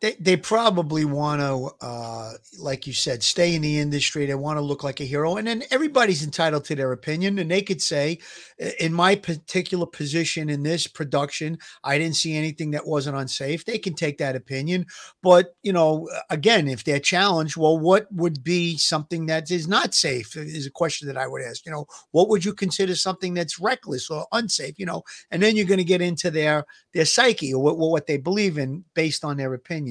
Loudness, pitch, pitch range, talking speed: -23 LUFS, 160 Hz, 145-180 Hz, 215 wpm